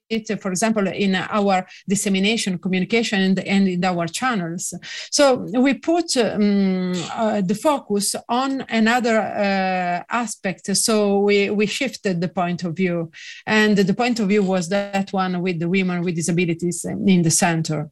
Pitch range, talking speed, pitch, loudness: 185-220 Hz, 155 wpm, 200 Hz, -20 LUFS